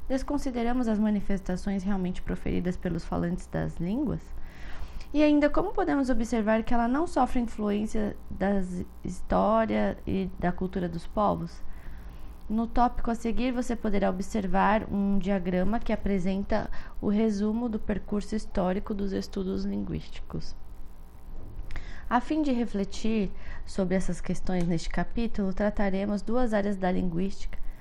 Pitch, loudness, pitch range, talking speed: 200 Hz, -29 LUFS, 180-225 Hz, 125 wpm